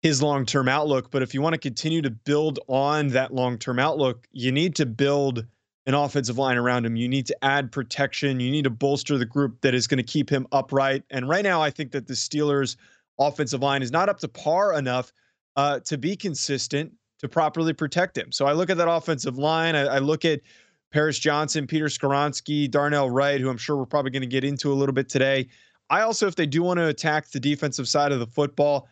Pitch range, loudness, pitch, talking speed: 135-150 Hz, -24 LUFS, 140 Hz, 230 wpm